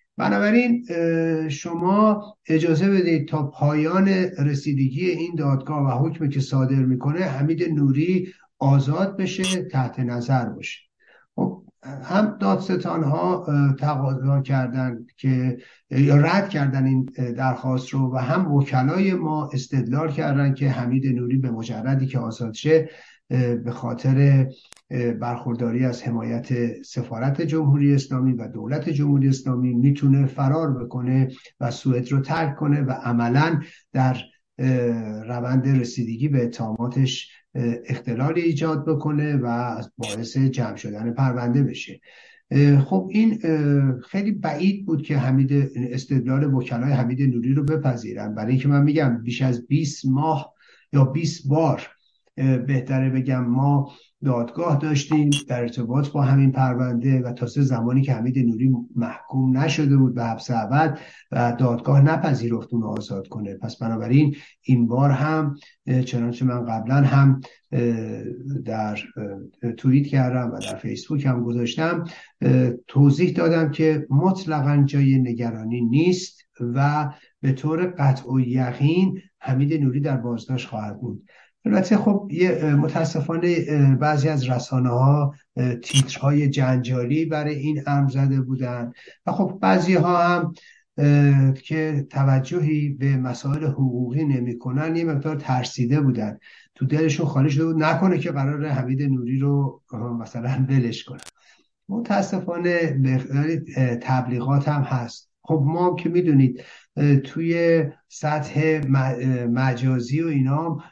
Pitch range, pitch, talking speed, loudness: 125-155 Hz, 135 Hz, 125 wpm, -22 LUFS